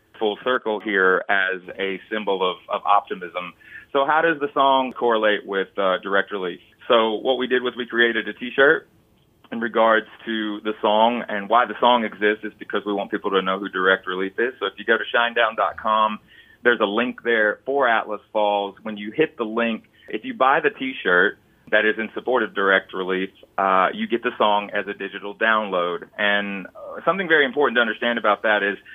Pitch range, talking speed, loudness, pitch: 100-120 Hz, 205 wpm, -21 LUFS, 105 Hz